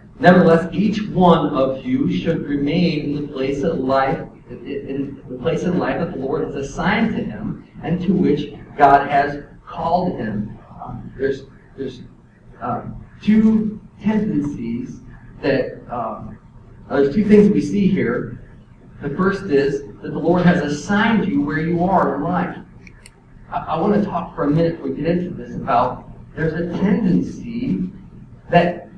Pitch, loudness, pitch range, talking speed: 165 Hz, -19 LUFS, 140-190 Hz, 160 wpm